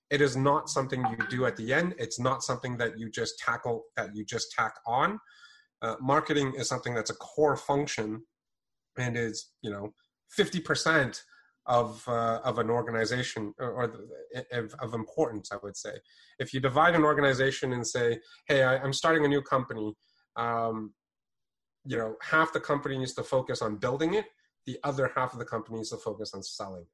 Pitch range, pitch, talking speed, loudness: 115-145 Hz, 130 Hz, 190 wpm, -30 LUFS